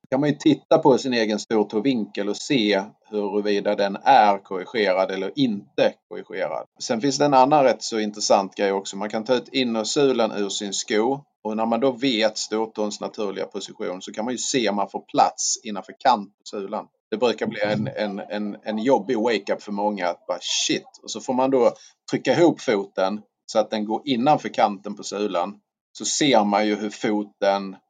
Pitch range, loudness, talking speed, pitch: 100-110 Hz, -22 LUFS, 200 wpm, 105 Hz